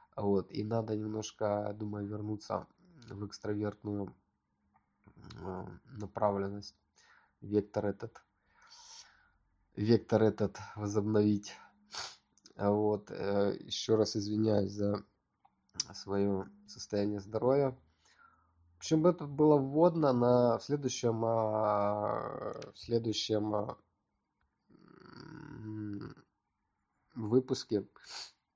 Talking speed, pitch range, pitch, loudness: 65 wpm, 100-115 Hz, 105 Hz, -33 LUFS